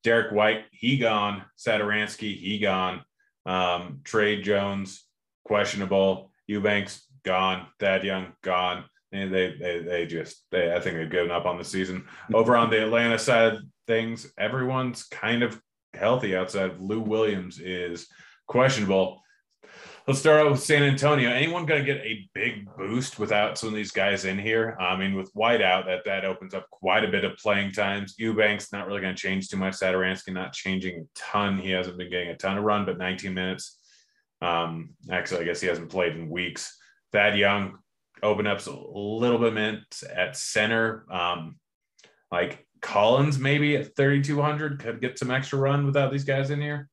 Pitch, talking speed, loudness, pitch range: 105 Hz, 180 wpm, -25 LUFS, 95-115 Hz